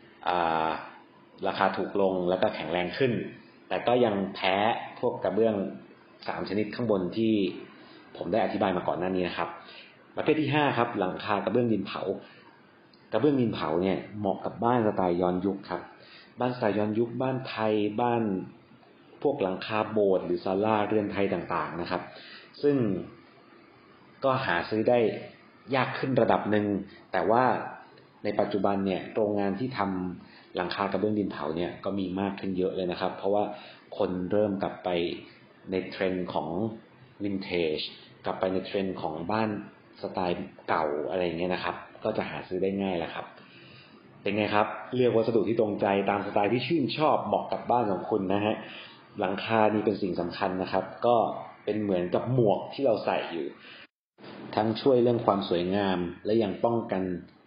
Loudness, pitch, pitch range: -28 LUFS, 100 Hz, 90-110 Hz